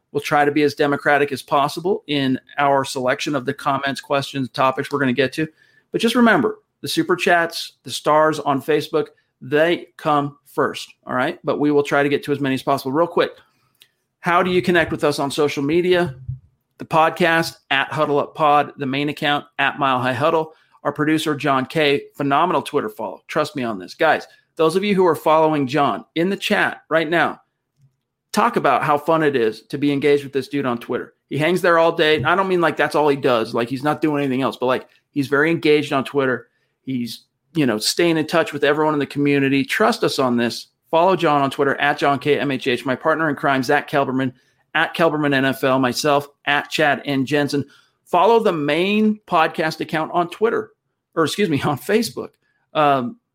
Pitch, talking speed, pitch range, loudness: 145 Hz, 205 wpm, 135-160 Hz, -19 LUFS